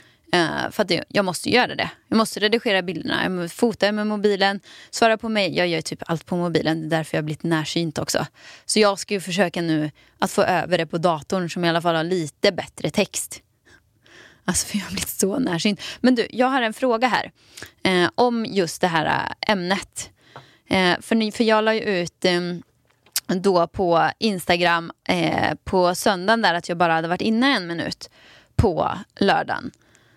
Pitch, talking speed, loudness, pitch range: 180 Hz, 190 wpm, -21 LUFS, 165-210 Hz